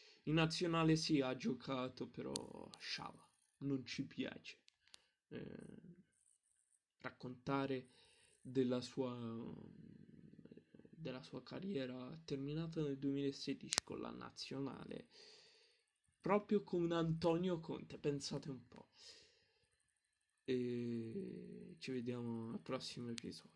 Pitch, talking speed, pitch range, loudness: 140 Hz, 95 wpm, 125-200 Hz, -43 LUFS